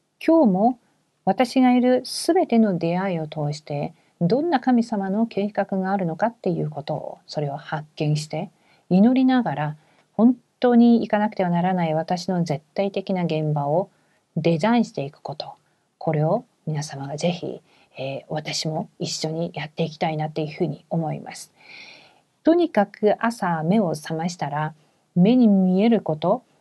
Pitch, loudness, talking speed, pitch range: 180 Hz, -22 LUFS, 300 characters per minute, 155-215 Hz